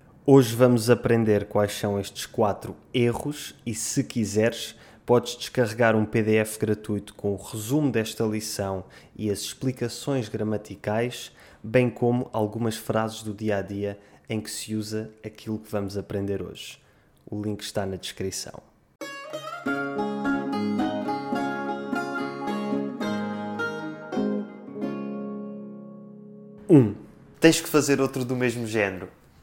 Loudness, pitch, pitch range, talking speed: -26 LUFS, 110 Hz, 100-120 Hz, 115 wpm